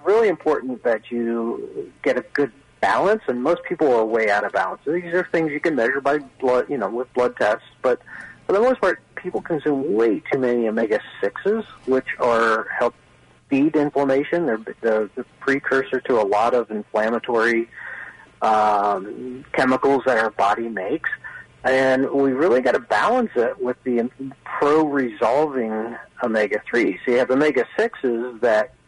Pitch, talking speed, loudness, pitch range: 130 Hz, 165 wpm, -21 LUFS, 115-145 Hz